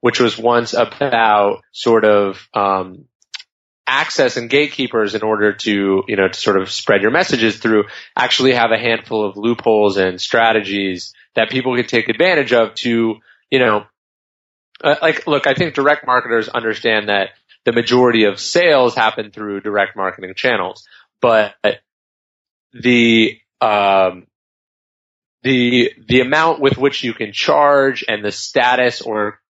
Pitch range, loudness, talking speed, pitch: 100-125 Hz, -15 LUFS, 145 wpm, 110 Hz